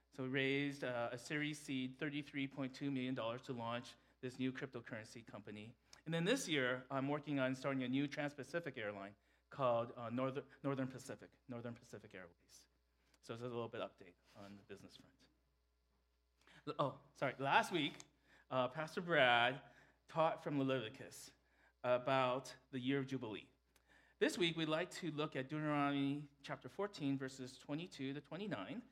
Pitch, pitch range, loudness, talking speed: 130 Hz, 120-145 Hz, -42 LUFS, 160 wpm